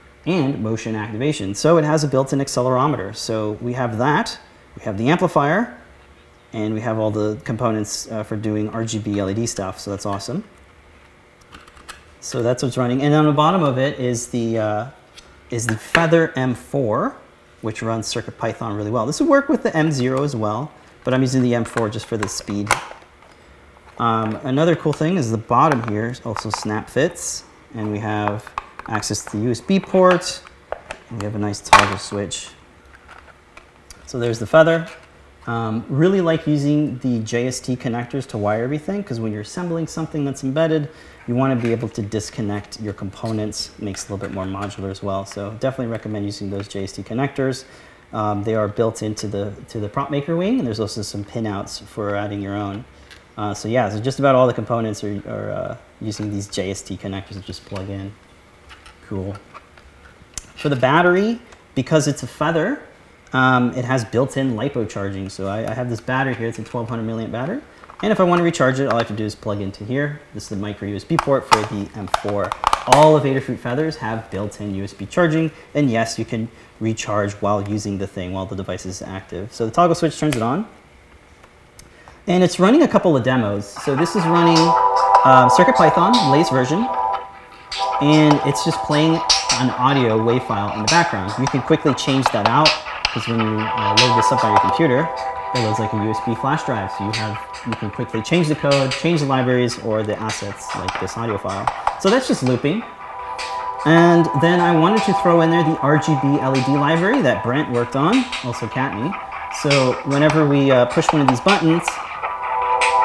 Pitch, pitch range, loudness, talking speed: 115 Hz, 105-140 Hz, -19 LUFS, 190 wpm